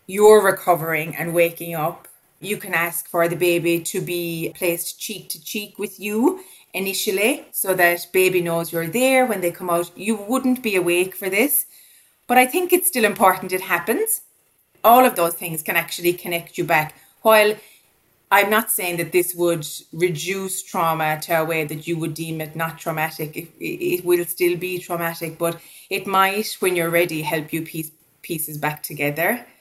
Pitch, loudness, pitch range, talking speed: 175 Hz, -20 LUFS, 165-205 Hz, 180 wpm